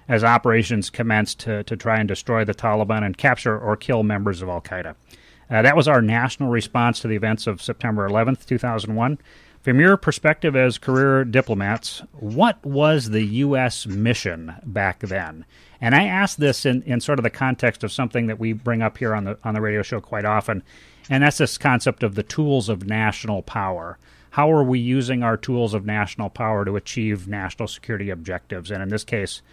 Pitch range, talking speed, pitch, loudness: 105-125 Hz, 195 wpm, 110 Hz, -21 LUFS